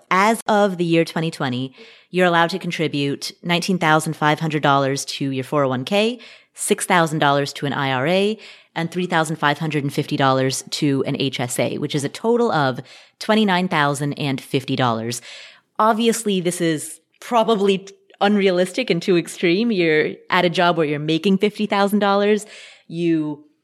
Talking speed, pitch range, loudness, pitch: 115 wpm, 145-200 Hz, -19 LUFS, 165 Hz